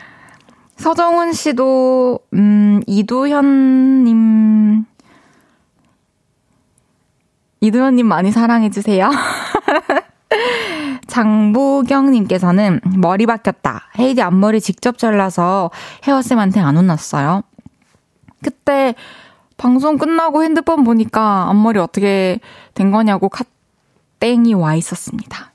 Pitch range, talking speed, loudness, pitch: 205-275 Hz, 205 characters per minute, -14 LUFS, 230 Hz